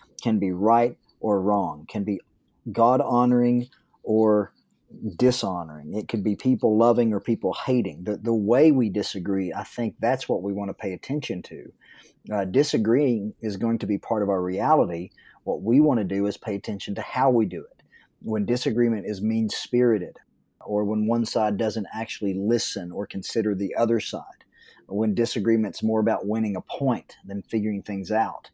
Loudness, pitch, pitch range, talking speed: -24 LUFS, 110 Hz, 100-115 Hz, 180 wpm